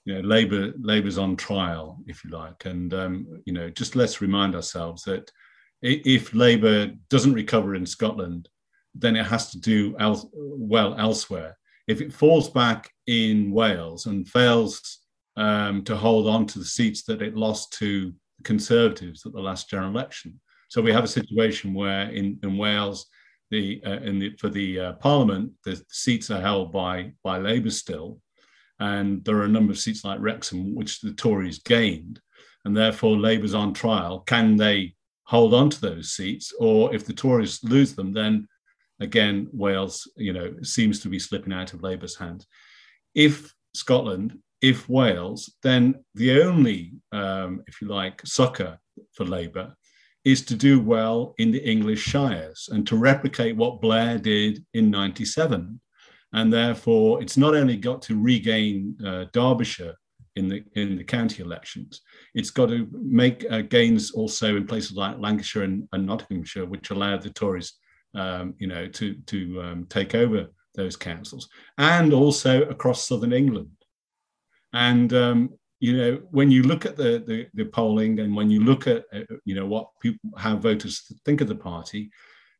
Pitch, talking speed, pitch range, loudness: 110 Hz, 170 wpm, 100-125 Hz, -23 LUFS